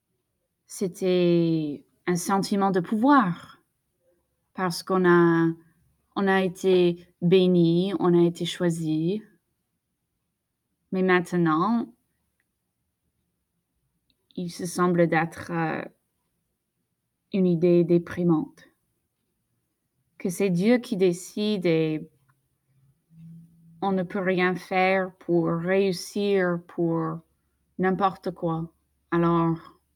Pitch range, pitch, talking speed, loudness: 165-190 Hz, 175 Hz, 85 wpm, -24 LUFS